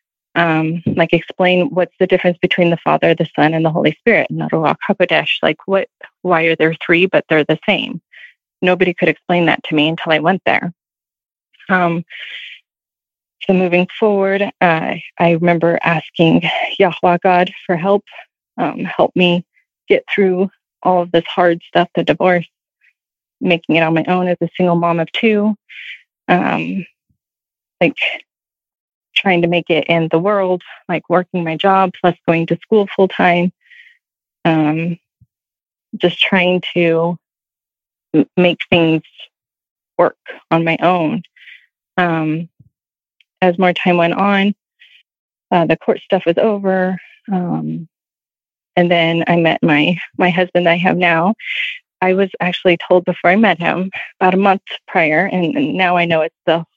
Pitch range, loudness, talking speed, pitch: 165-185 Hz, -15 LUFS, 155 wpm, 175 Hz